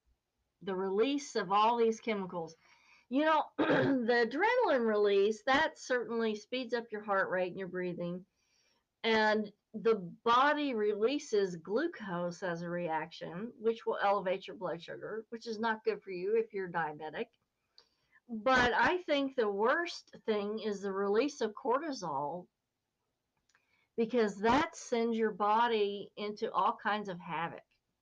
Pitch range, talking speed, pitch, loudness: 195-235 Hz, 140 wpm, 220 Hz, -33 LUFS